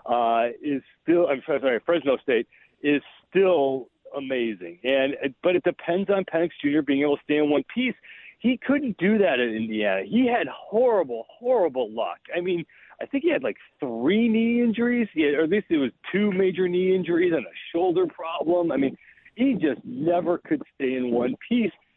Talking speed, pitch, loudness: 190 wpm, 180 Hz, -24 LUFS